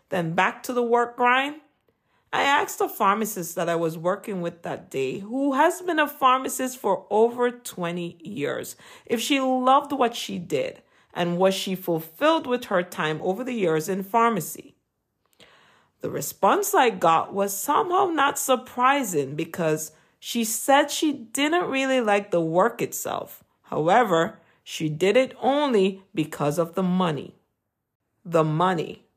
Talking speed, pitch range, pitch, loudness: 150 wpm, 170-260 Hz, 205 Hz, -24 LUFS